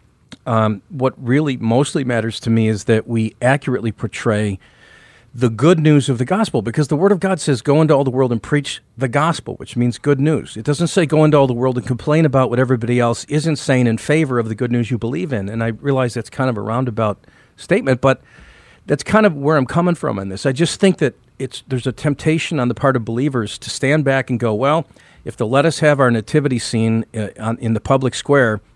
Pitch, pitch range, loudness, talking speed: 130 Hz, 115-150 Hz, -17 LUFS, 235 wpm